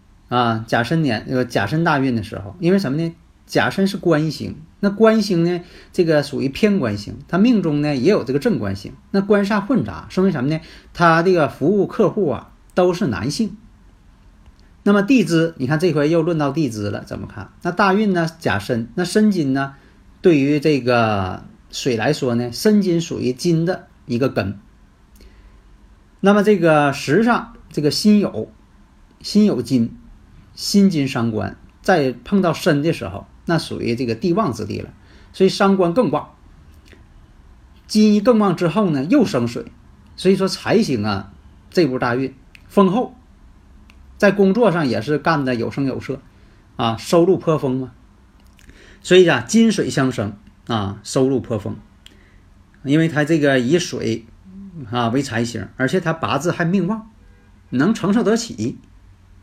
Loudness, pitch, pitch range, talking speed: -18 LUFS, 140 Hz, 110-180 Hz, 230 characters per minute